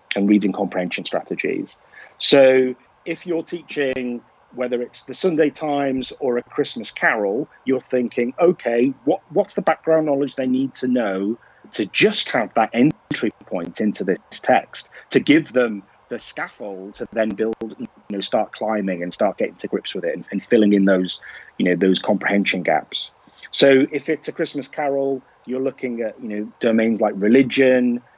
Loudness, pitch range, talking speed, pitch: -20 LUFS, 105-140 Hz, 175 wpm, 125 Hz